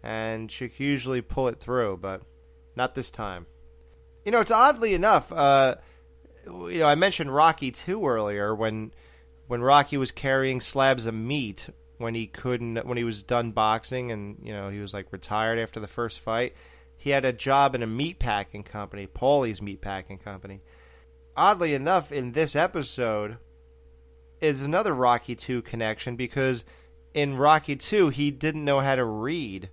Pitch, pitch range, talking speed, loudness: 115 Hz, 95-135 Hz, 170 wpm, -25 LUFS